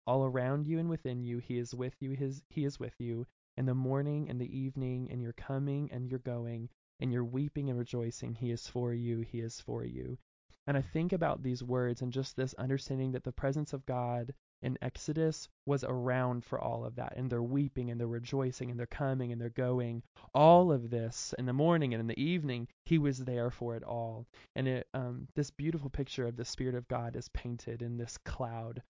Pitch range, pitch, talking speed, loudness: 120-135 Hz, 125 Hz, 220 wpm, -35 LUFS